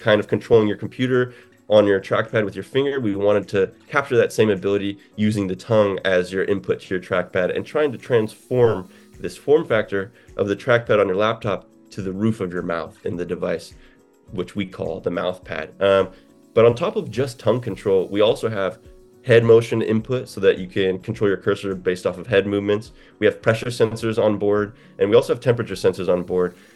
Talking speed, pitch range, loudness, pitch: 215 wpm, 100-120 Hz, -21 LUFS, 105 Hz